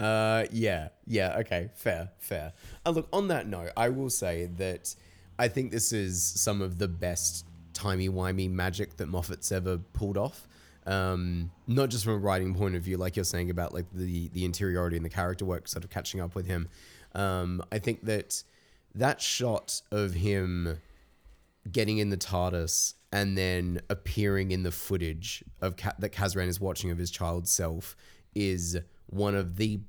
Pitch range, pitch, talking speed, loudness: 90-100 Hz, 95 Hz, 180 wpm, -31 LUFS